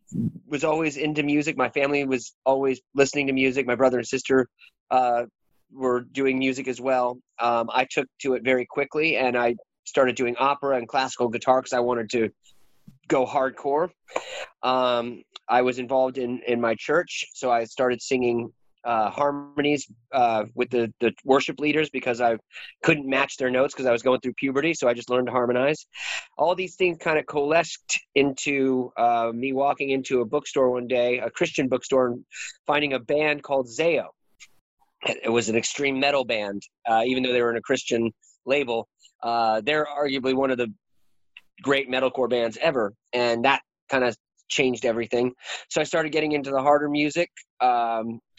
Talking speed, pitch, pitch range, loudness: 180 wpm, 130 Hz, 120-140 Hz, -24 LUFS